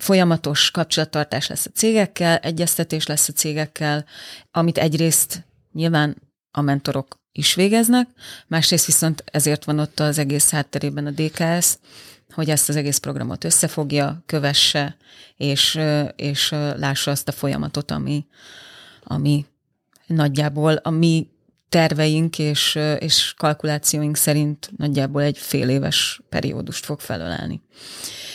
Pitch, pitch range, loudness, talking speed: 150 Hz, 145-165 Hz, -19 LUFS, 120 wpm